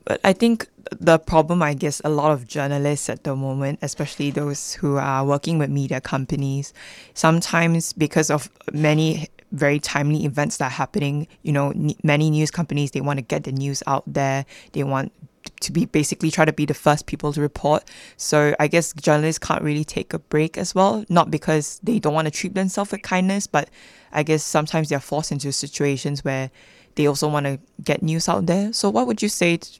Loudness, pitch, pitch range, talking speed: -21 LUFS, 150 Hz, 140-165 Hz, 205 wpm